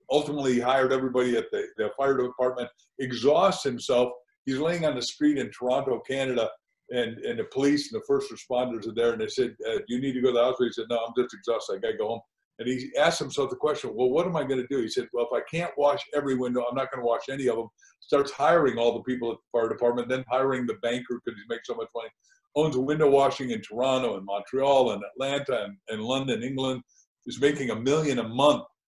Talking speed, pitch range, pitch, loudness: 250 wpm, 125-165 Hz, 135 Hz, -27 LUFS